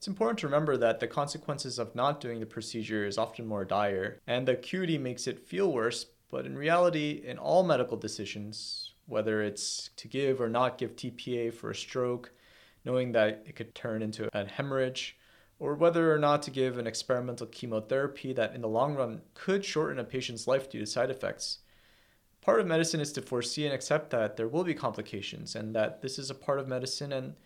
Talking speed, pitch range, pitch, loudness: 205 wpm, 110-145 Hz, 125 Hz, -32 LUFS